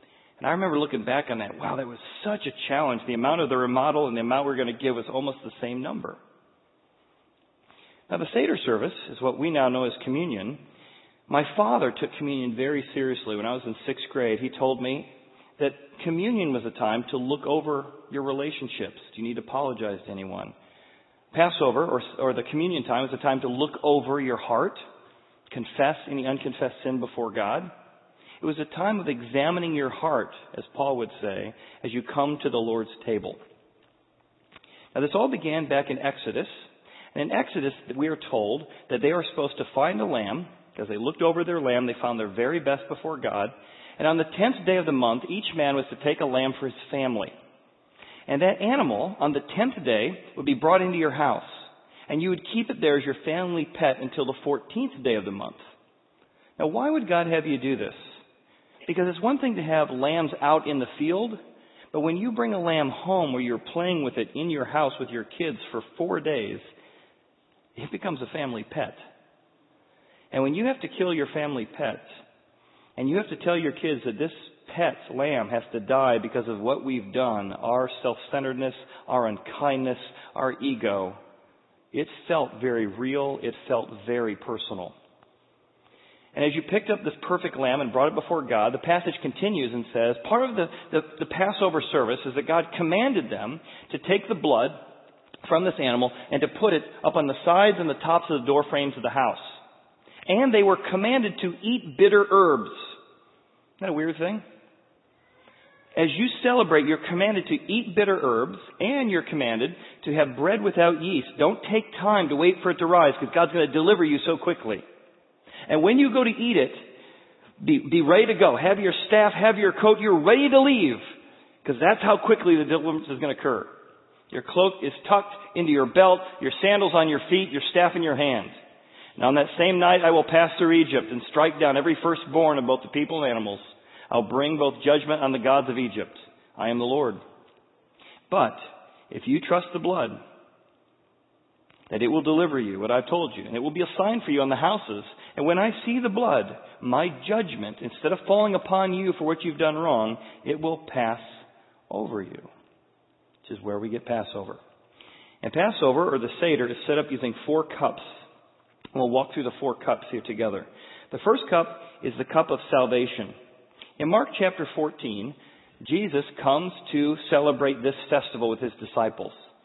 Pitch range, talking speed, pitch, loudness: 130-185 Hz, 200 wpm, 150 Hz, -25 LUFS